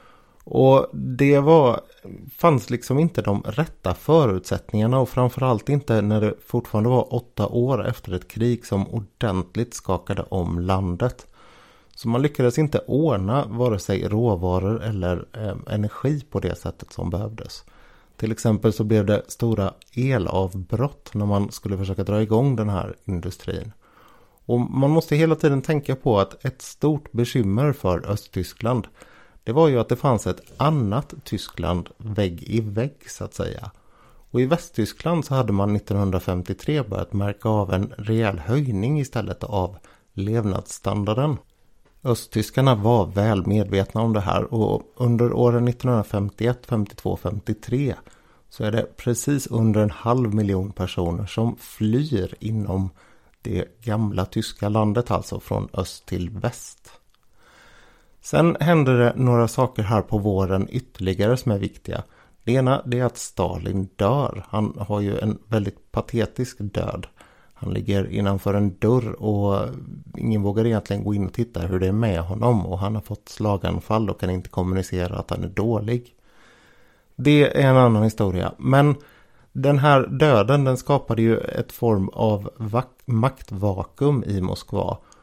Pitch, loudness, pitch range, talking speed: 110 Hz, -22 LUFS, 100-125 Hz, 150 wpm